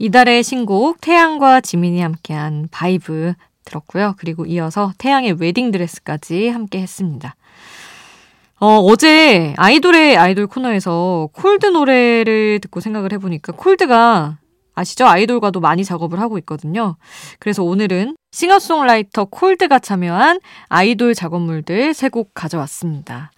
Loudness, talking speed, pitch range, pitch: -14 LUFS, 325 characters per minute, 170-240 Hz, 200 Hz